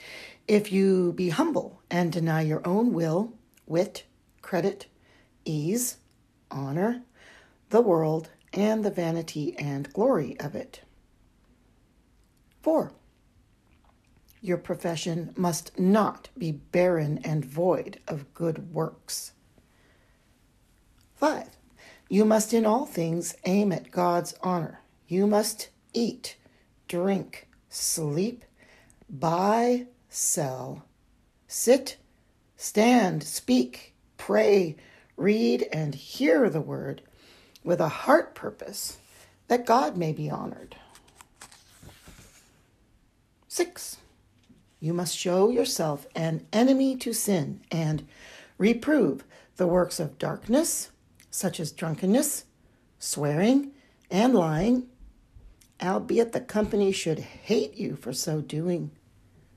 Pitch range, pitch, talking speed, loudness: 160-220 Hz, 180 Hz, 100 wpm, -27 LUFS